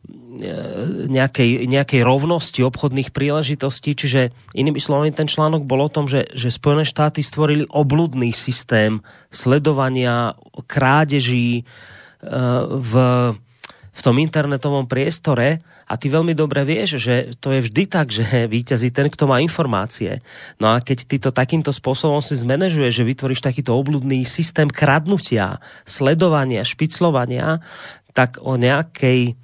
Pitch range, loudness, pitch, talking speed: 125-150 Hz, -18 LUFS, 135 Hz, 125 wpm